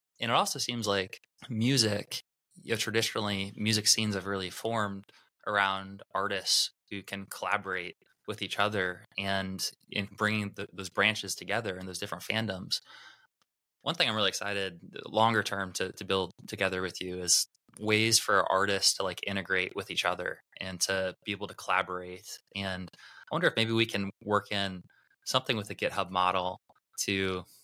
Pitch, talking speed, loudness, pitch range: 100 Hz, 165 wpm, -30 LUFS, 95-110 Hz